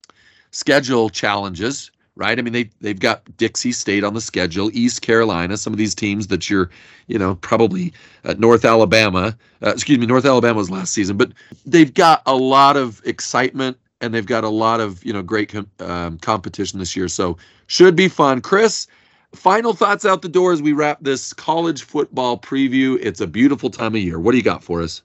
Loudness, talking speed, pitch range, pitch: -17 LUFS, 205 wpm, 105-135 Hz, 115 Hz